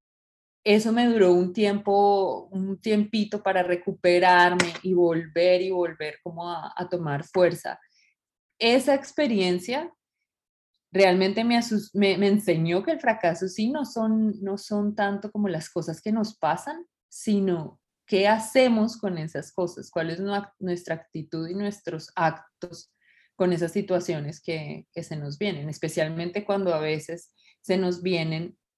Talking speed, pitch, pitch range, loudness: 145 wpm, 185 Hz, 170-205 Hz, -25 LUFS